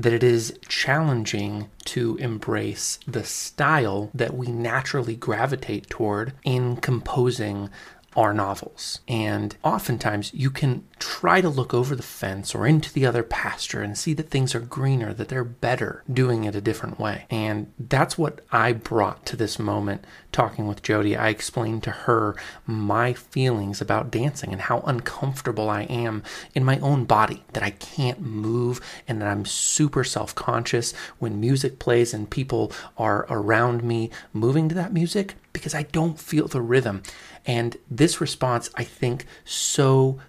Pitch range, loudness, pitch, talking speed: 110-135 Hz, -24 LUFS, 120 Hz, 160 wpm